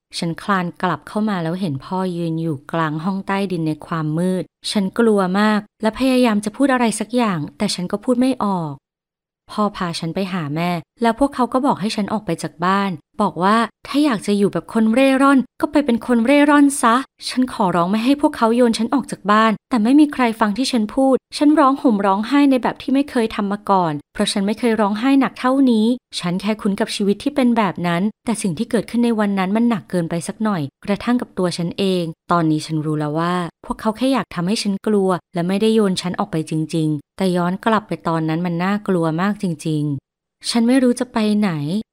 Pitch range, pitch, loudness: 175-235 Hz, 205 Hz, -18 LUFS